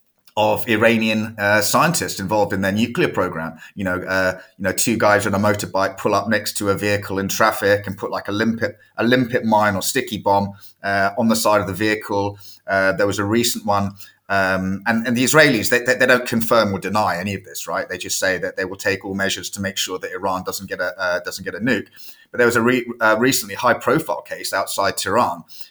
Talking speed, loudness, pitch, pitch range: 235 wpm, -19 LUFS, 105 Hz, 95-115 Hz